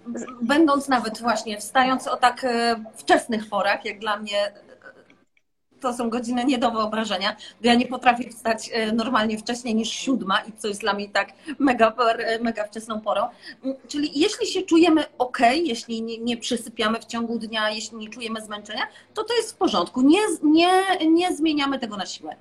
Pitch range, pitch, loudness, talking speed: 220-280 Hz, 235 Hz, -23 LUFS, 170 wpm